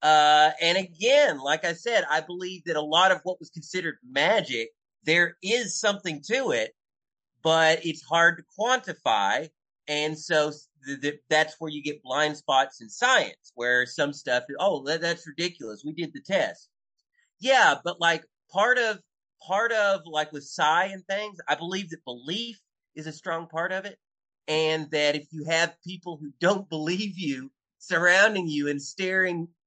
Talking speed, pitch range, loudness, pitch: 170 wpm, 150-190 Hz, -25 LUFS, 170 Hz